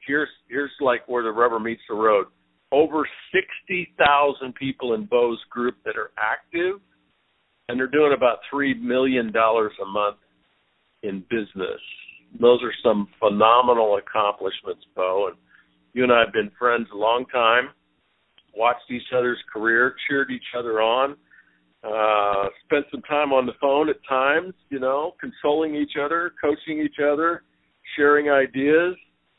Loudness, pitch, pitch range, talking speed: -22 LUFS, 125 Hz, 110-145 Hz, 150 wpm